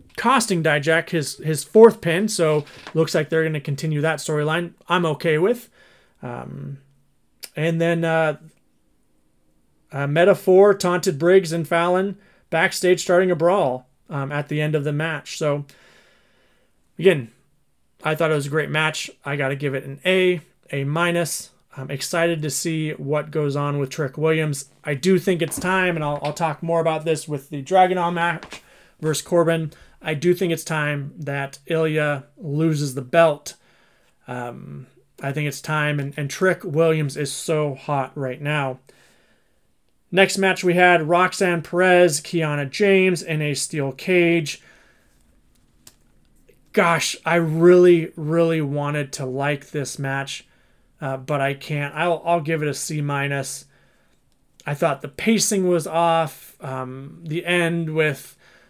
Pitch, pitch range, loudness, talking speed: 155 Hz, 145-170 Hz, -21 LUFS, 155 wpm